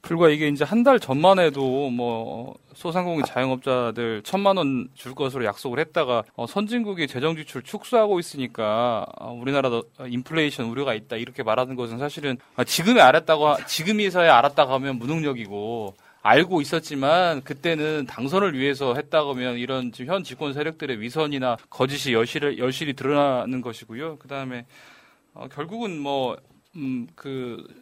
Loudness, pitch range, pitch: -23 LUFS, 125-160 Hz, 140 Hz